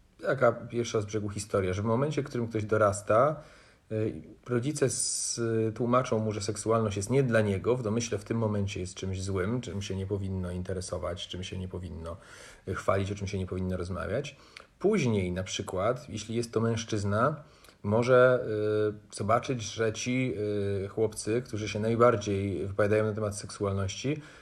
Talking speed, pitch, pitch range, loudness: 155 wpm, 105 Hz, 100-115 Hz, -30 LUFS